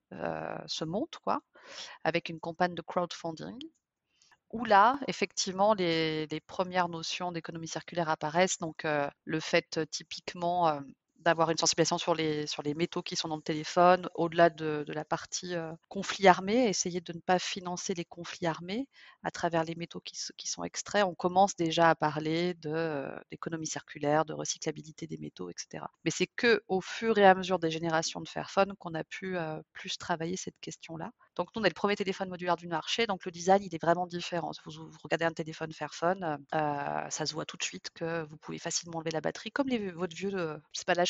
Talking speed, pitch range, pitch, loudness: 205 wpm, 160-185 Hz, 170 Hz, -31 LUFS